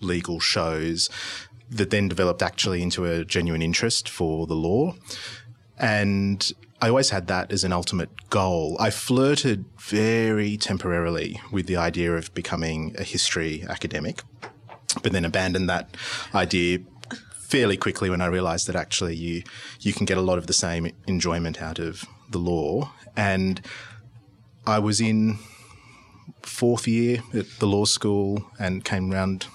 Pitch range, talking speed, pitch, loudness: 90-110 Hz, 150 wpm, 95 Hz, -24 LUFS